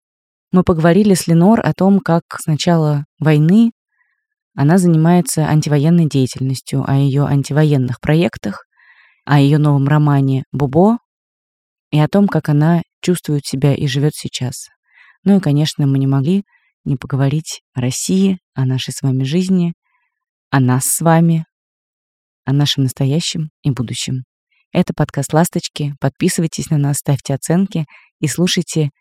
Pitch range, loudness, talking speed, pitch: 140-175 Hz, -15 LUFS, 140 wpm, 150 Hz